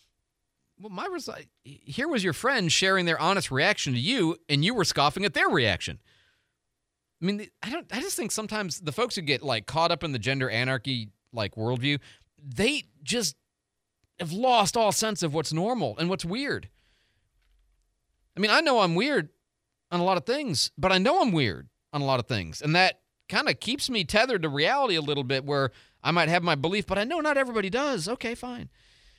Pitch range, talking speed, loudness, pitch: 135-210 Hz, 210 wpm, -26 LUFS, 170 Hz